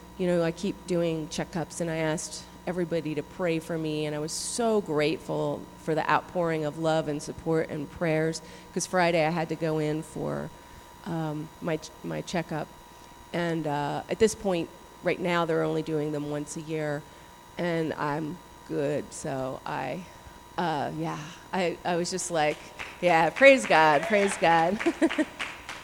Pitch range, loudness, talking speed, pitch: 150-170 Hz, -28 LUFS, 165 wpm, 160 Hz